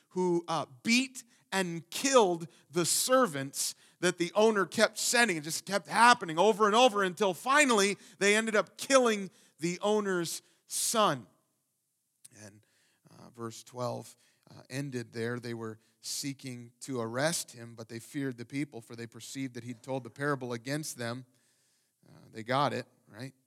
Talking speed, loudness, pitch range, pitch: 155 wpm, -30 LUFS, 120-200 Hz, 150 Hz